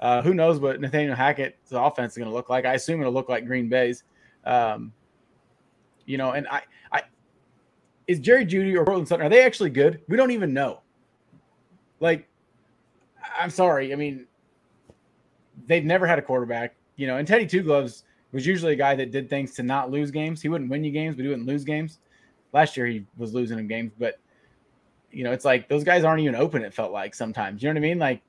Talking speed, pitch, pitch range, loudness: 220 wpm, 140 Hz, 125-165 Hz, -24 LUFS